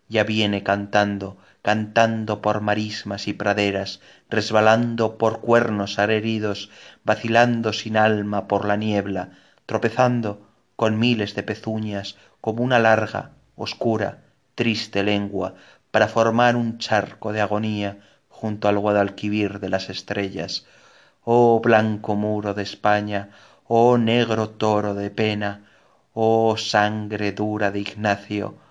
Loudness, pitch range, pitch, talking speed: -22 LUFS, 100-110 Hz, 105 Hz, 115 wpm